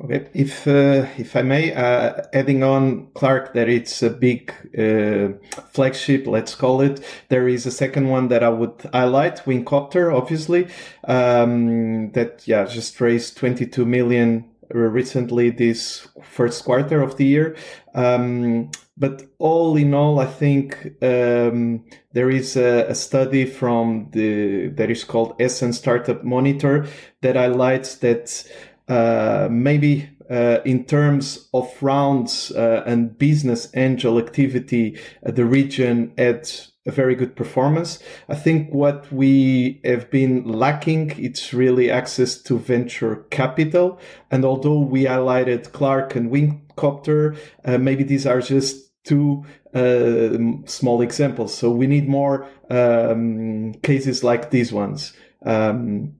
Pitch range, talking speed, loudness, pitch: 120-140 Hz, 135 wpm, -19 LUFS, 125 Hz